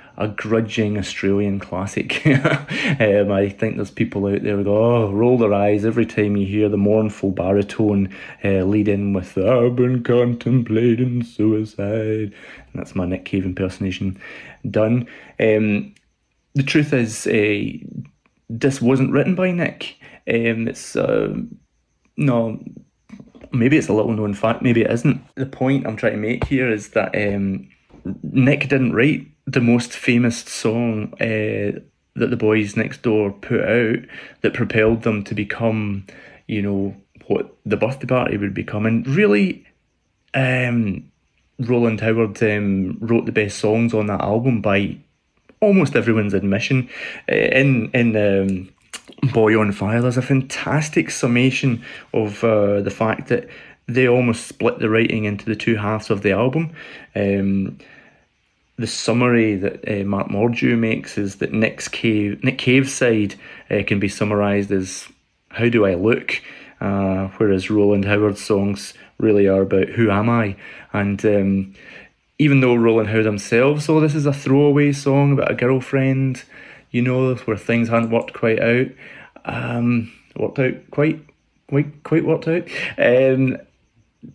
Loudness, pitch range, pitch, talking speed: -19 LUFS, 100-125 Hz, 110 Hz, 150 wpm